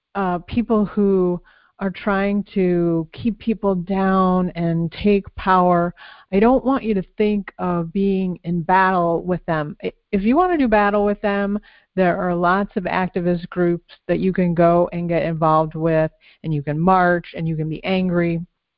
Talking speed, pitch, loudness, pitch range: 175 wpm, 185 Hz, -20 LUFS, 170-205 Hz